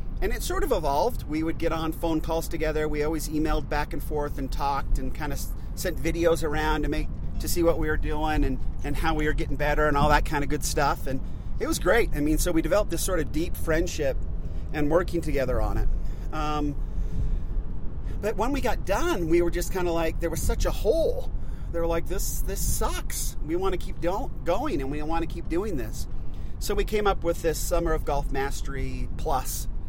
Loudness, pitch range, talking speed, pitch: -28 LUFS, 140-165 Hz, 230 wpm, 155 Hz